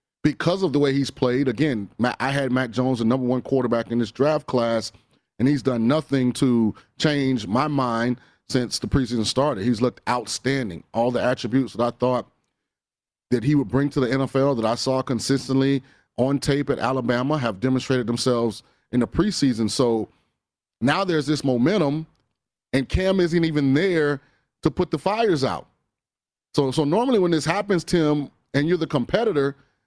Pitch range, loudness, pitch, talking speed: 125-145 Hz, -22 LUFS, 130 Hz, 175 wpm